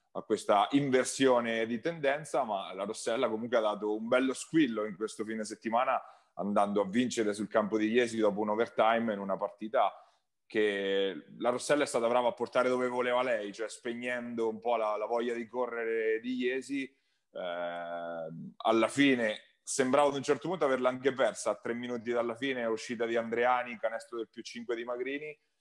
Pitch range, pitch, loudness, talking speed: 110-125 Hz, 120 Hz, -31 LUFS, 185 wpm